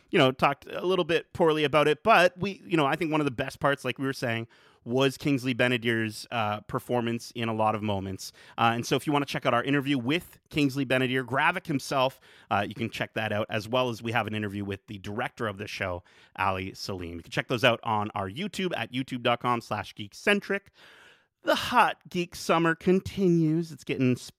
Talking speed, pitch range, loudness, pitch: 220 wpm, 110-150 Hz, -27 LUFS, 130 Hz